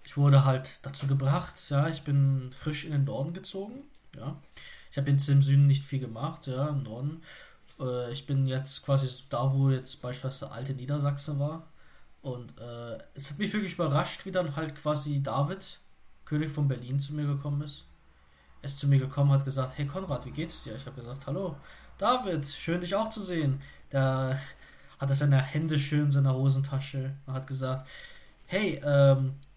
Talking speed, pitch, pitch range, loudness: 185 wpm, 140 Hz, 135-150 Hz, -29 LUFS